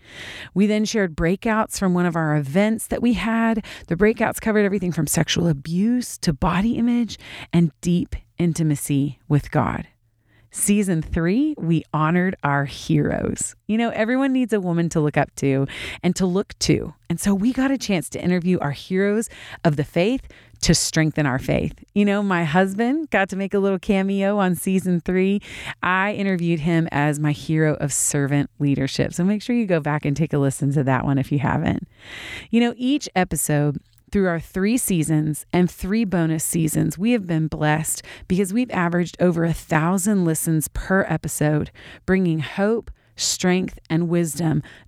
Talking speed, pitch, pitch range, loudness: 175 wpm, 175 Hz, 150-200 Hz, -21 LUFS